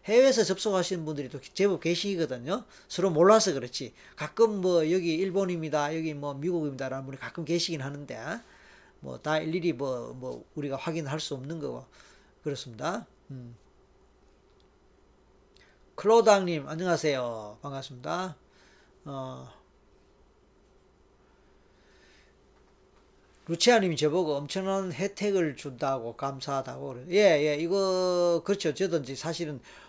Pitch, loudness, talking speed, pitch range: 160 Hz, -28 LUFS, 265 characters per minute, 140-185 Hz